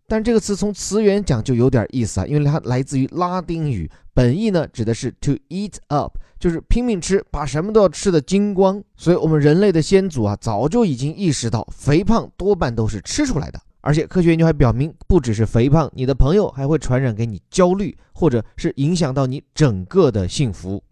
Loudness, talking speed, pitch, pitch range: -19 LUFS, 330 characters per minute, 150 Hz, 125-185 Hz